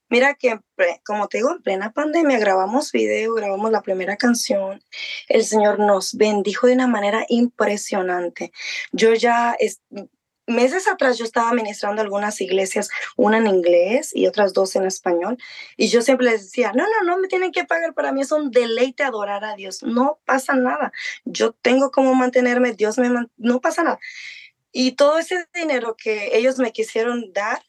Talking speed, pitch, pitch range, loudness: 180 wpm, 240 Hz, 210-270 Hz, -19 LUFS